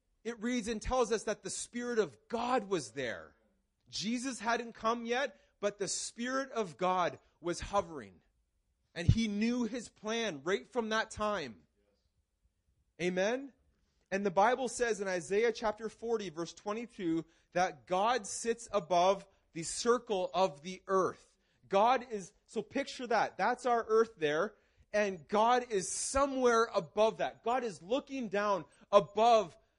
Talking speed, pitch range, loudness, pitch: 145 wpm, 185-235 Hz, -34 LUFS, 215 Hz